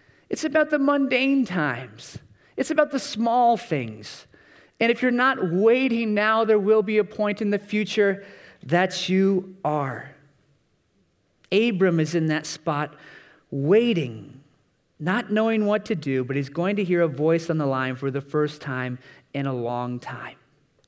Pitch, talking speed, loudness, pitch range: 175 Hz, 160 wpm, -23 LUFS, 140-220 Hz